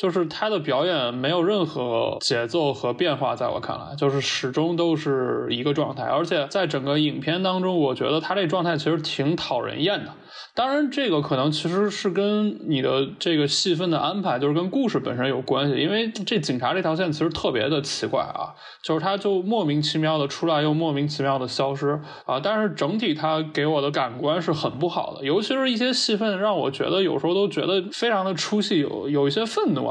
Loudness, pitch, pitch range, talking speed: -23 LUFS, 160 Hz, 145-195 Hz, 325 characters per minute